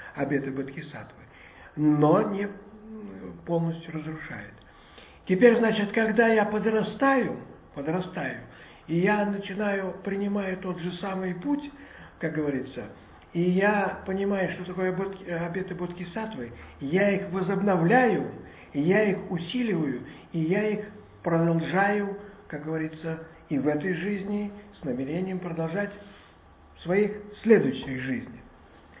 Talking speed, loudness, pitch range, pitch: 110 wpm, -27 LUFS, 160-205 Hz, 185 Hz